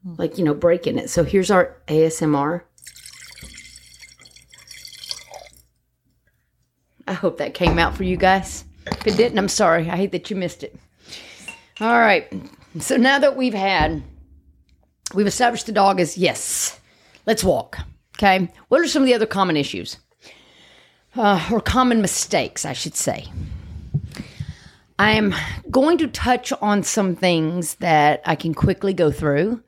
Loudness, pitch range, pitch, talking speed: -19 LUFS, 160-220 Hz, 190 Hz, 150 wpm